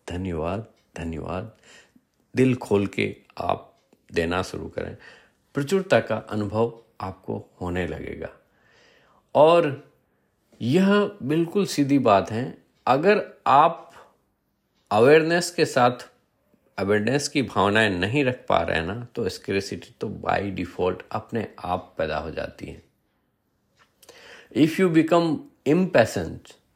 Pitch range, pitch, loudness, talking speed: 95-145 Hz, 110 Hz, -23 LUFS, 110 wpm